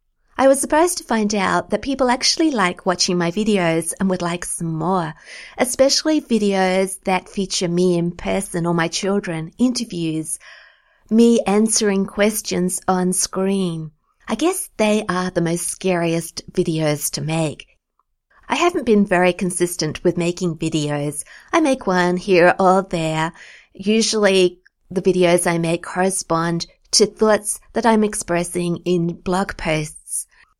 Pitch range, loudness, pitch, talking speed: 170-210 Hz, -19 LUFS, 185 Hz, 140 wpm